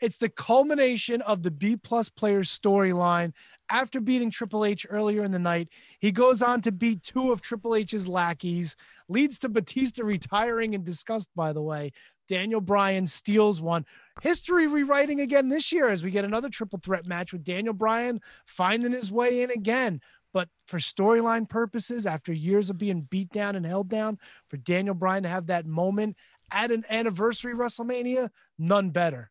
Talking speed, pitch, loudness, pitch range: 175 wpm, 210 Hz, -26 LUFS, 185-235 Hz